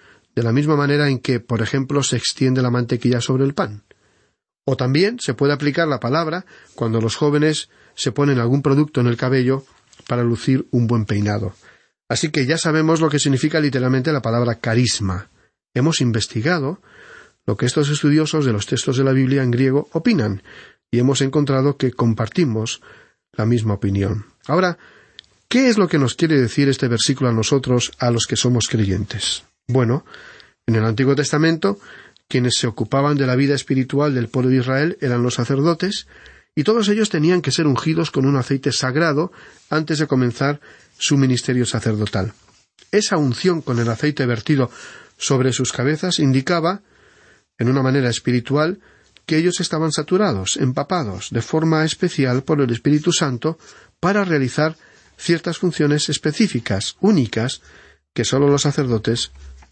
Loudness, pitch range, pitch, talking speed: -19 LUFS, 120-155 Hz, 135 Hz, 160 wpm